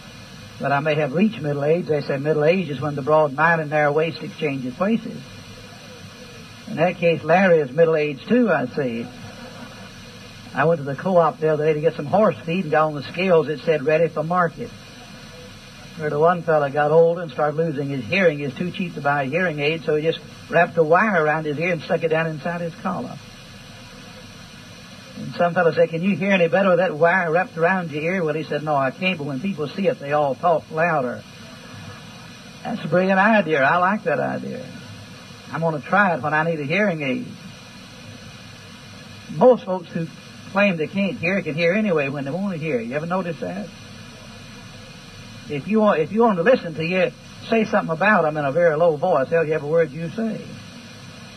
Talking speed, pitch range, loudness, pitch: 215 wpm, 150-185 Hz, -20 LUFS, 165 Hz